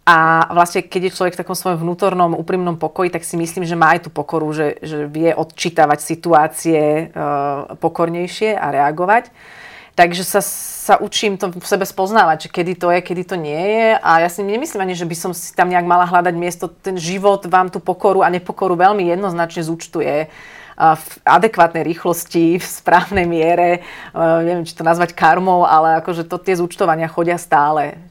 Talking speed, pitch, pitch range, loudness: 180 wpm, 175 Hz, 165-185 Hz, -16 LUFS